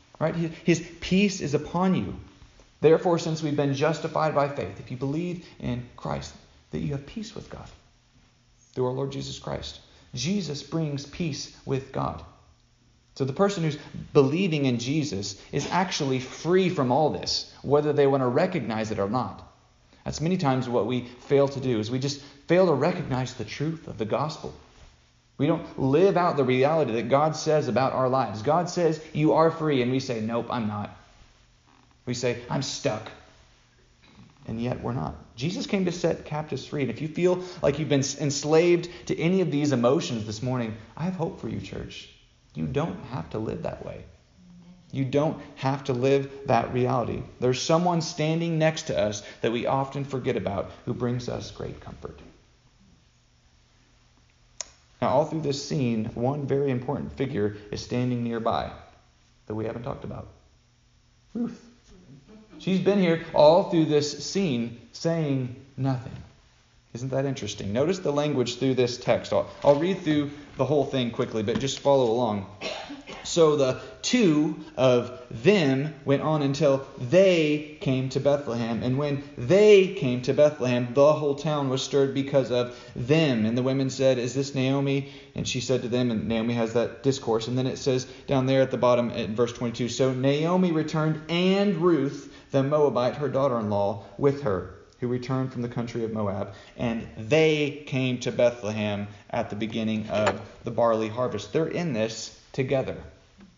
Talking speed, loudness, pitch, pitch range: 175 wpm, -26 LUFS, 135 Hz, 120-155 Hz